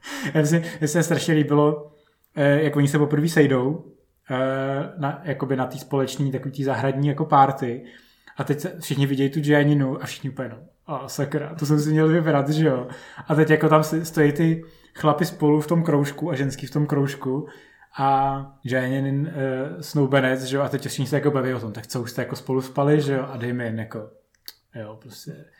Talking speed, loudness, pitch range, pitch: 200 wpm, -22 LUFS, 135-150 Hz, 140 Hz